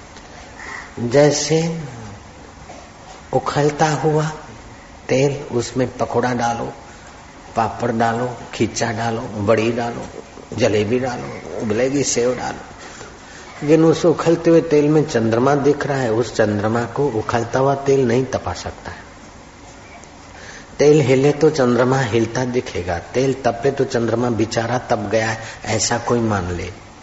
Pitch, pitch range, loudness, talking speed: 120 Hz, 110-140 Hz, -18 LUFS, 125 wpm